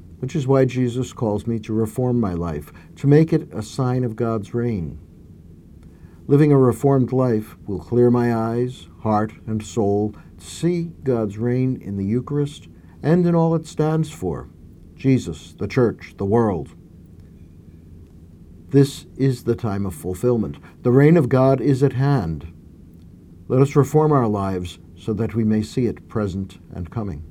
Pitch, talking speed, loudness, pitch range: 110 Hz, 165 wpm, -20 LUFS, 85-130 Hz